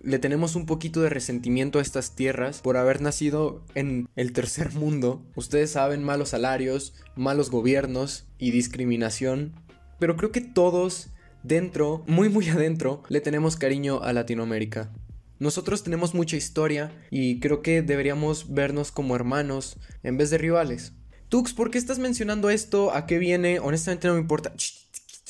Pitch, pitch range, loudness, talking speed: 145 Hz, 130-165 Hz, -25 LUFS, 155 wpm